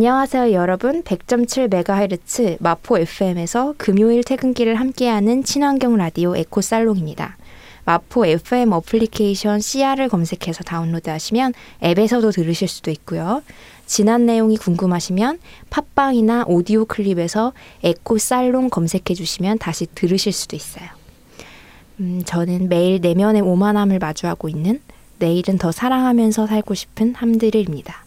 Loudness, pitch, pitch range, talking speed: -18 LUFS, 210 Hz, 175-235 Hz, 330 characters per minute